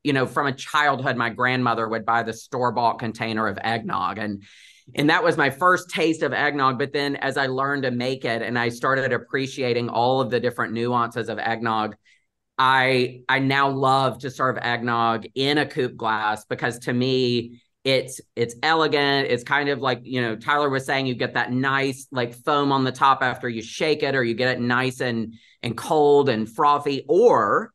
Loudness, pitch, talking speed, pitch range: -22 LUFS, 125 Hz, 200 wpm, 115-135 Hz